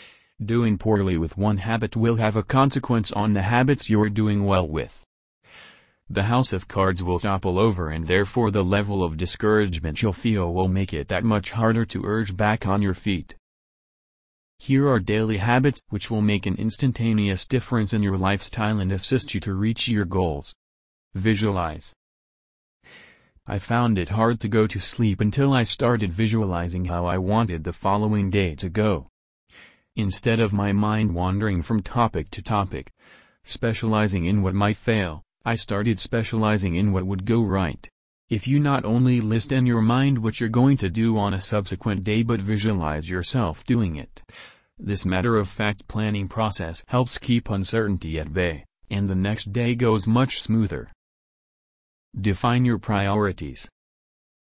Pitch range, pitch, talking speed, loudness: 95-115 Hz, 105 Hz, 165 wpm, -23 LUFS